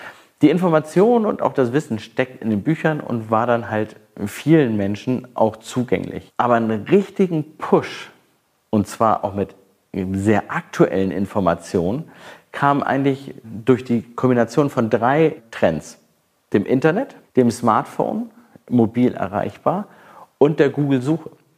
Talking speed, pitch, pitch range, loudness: 130 wpm, 125 Hz, 110-155 Hz, -19 LUFS